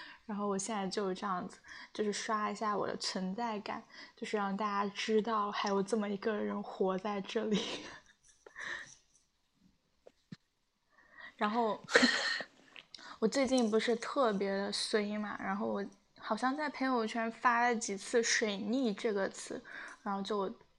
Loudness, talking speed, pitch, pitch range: -35 LUFS, 205 characters per minute, 215 Hz, 205-235 Hz